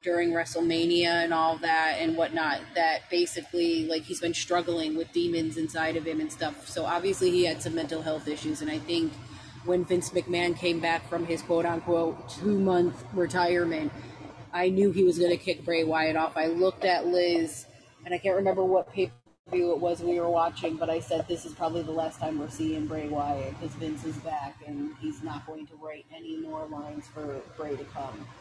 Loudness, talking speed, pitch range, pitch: -28 LUFS, 210 wpm, 155-175 Hz, 165 Hz